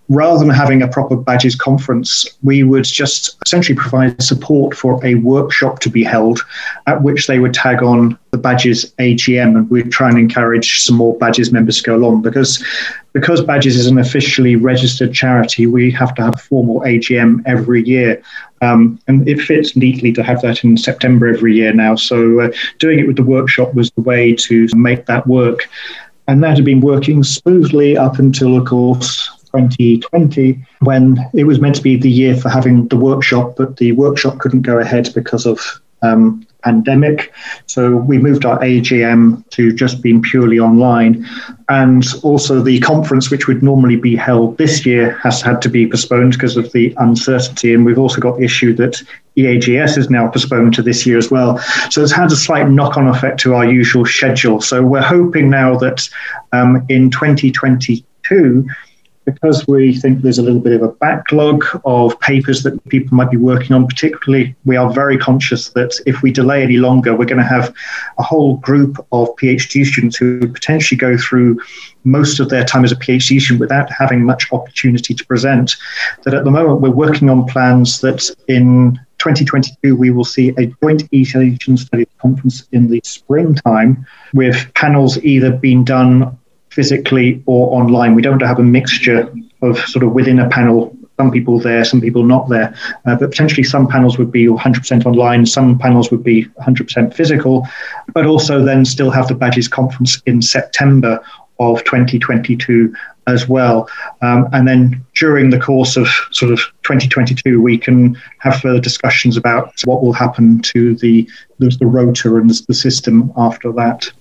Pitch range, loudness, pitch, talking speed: 120-135 Hz, -11 LUFS, 125 Hz, 180 wpm